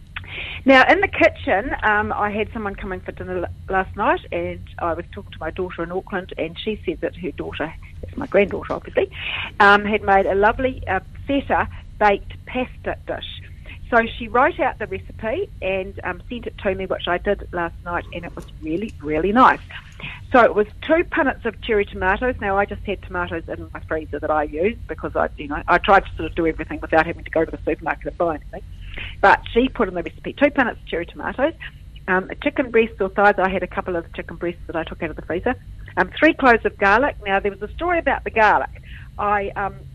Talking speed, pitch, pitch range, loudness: 225 wpm, 200 Hz, 175-230 Hz, -21 LUFS